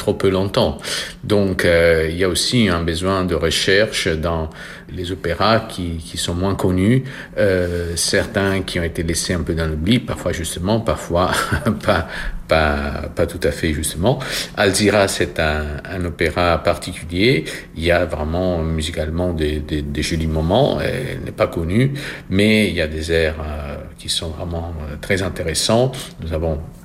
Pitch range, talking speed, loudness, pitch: 80-95 Hz, 170 wpm, -19 LUFS, 85 Hz